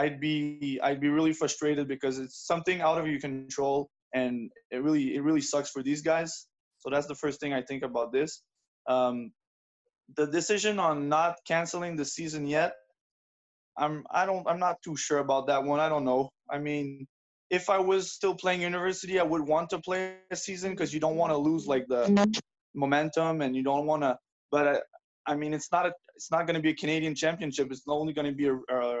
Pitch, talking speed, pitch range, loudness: 150 Hz, 215 wpm, 140-175 Hz, -29 LUFS